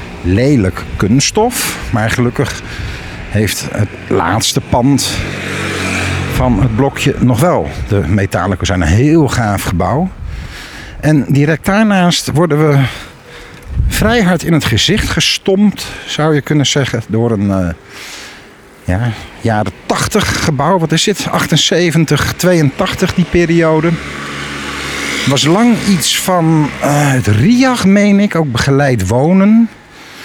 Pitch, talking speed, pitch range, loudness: 135 Hz, 125 wpm, 100-165 Hz, -12 LUFS